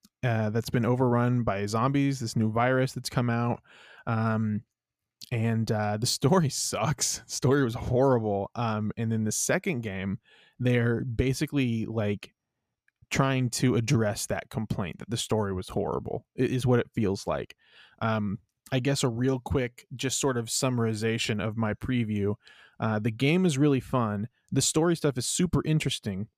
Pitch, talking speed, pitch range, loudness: 120 Hz, 160 wpm, 110-130 Hz, -28 LUFS